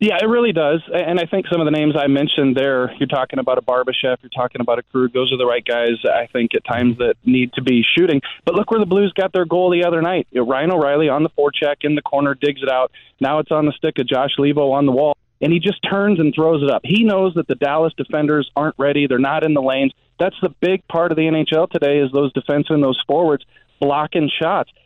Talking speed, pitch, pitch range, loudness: 255 wpm, 145 Hz, 135-165 Hz, -17 LUFS